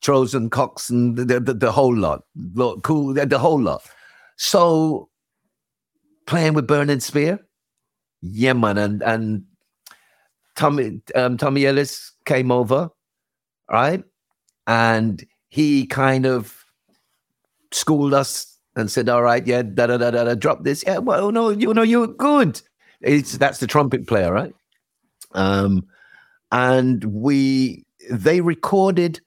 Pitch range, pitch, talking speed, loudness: 120-155 Hz, 135 Hz, 135 wpm, -19 LUFS